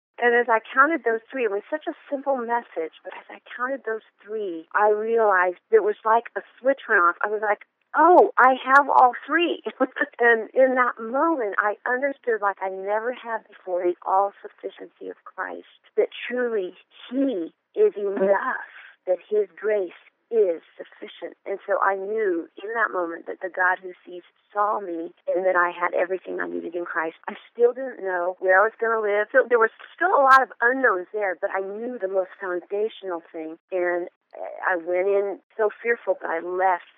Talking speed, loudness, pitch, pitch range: 195 wpm, -23 LUFS, 220 Hz, 185-265 Hz